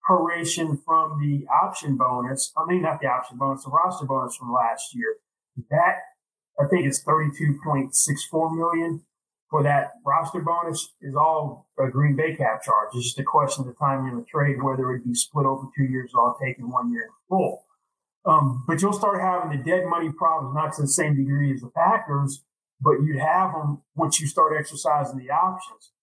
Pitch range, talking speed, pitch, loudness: 135-165 Hz, 205 wpm, 150 Hz, -22 LUFS